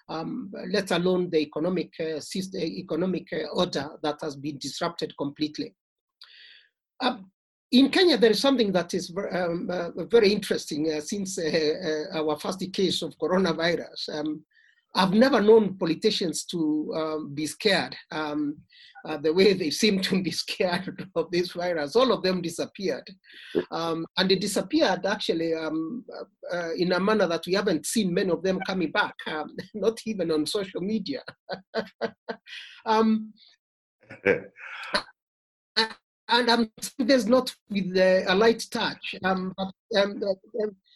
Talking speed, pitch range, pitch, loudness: 145 wpm, 165-215 Hz, 185 Hz, -26 LUFS